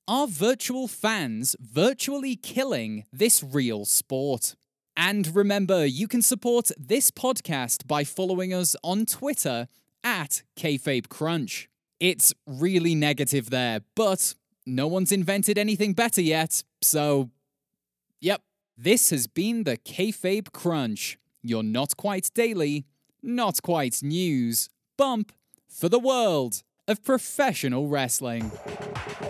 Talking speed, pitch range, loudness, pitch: 115 wpm, 140-215 Hz, -25 LUFS, 170 Hz